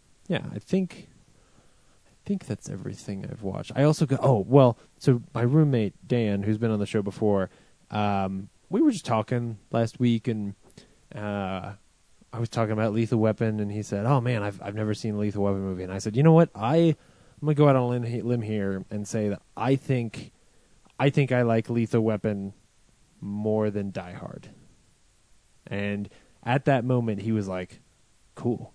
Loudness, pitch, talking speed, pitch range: -26 LUFS, 110 Hz, 190 wpm, 100-125 Hz